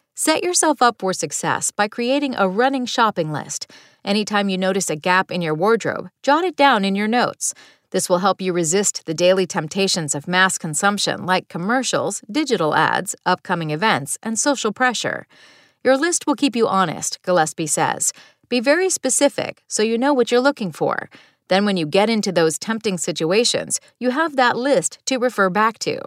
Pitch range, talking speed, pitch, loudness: 185-255 Hz, 180 wpm, 205 Hz, -19 LUFS